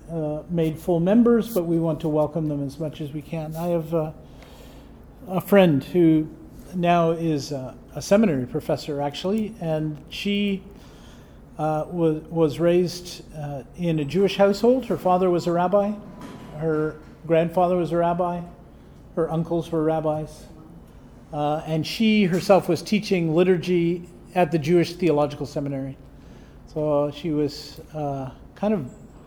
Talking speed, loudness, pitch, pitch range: 145 wpm, -23 LUFS, 165 Hz, 155-180 Hz